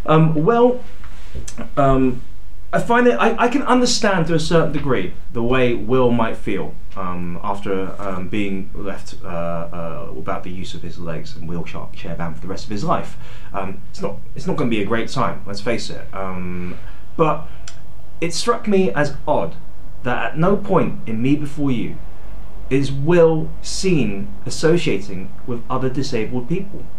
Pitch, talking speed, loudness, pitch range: 125 Hz, 175 wpm, -20 LUFS, 95-160 Hz